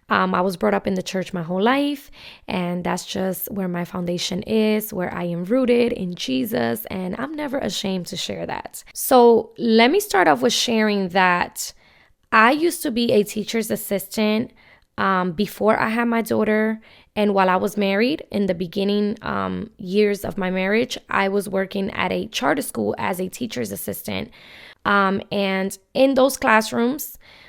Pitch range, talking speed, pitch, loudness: 185-230 Hz, 175 wpm, 205 Hz, -21 LUFS